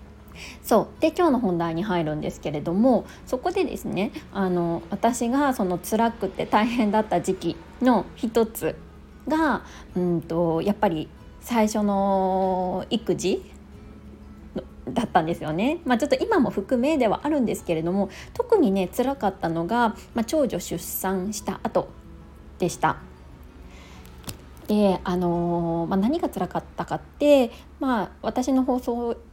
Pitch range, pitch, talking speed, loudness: 170-245 Hz, 200 Hz, 260 characters per minute, -24 LUFS